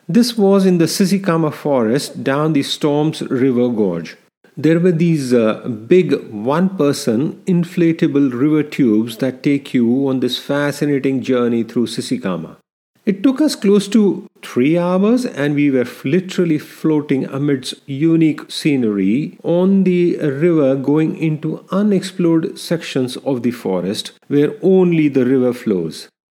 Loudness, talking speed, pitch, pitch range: -16 LUFS, 135 wpm, 150 Hz, 135-180 Hz